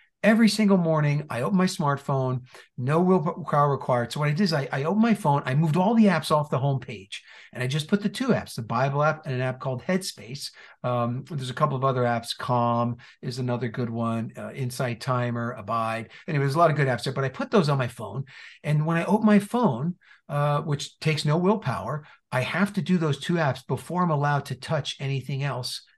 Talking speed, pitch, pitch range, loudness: 230 wpm, 145 Hz, 130-165 Hz, -25 LUFS